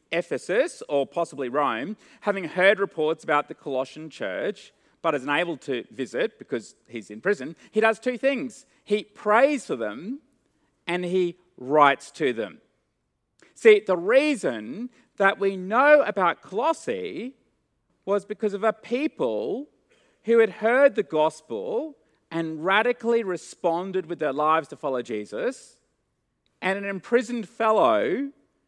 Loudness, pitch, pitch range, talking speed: -24 LUFS, 205 Hz, 160-255 Hz, 135 wpm